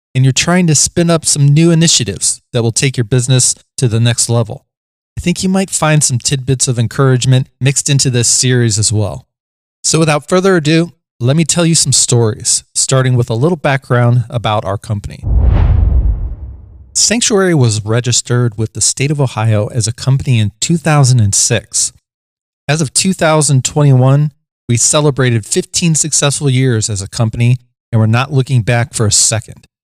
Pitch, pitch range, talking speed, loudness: 130 Hz, 115-150 Hz, 165 wpm, -12 LUFS